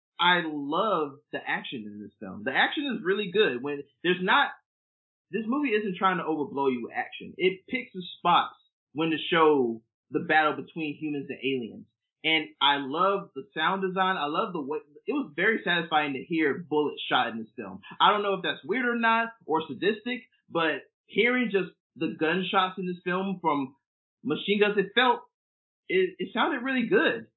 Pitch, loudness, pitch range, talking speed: 170 Hz, -27 LUFS, 145-205 Hz, 190 wpm